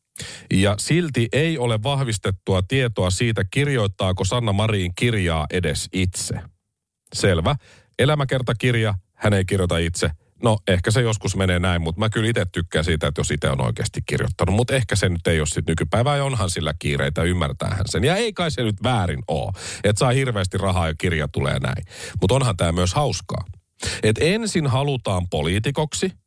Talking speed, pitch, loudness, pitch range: 175 wpm, 100 Hz, -21 LUFS, 90-125 Hz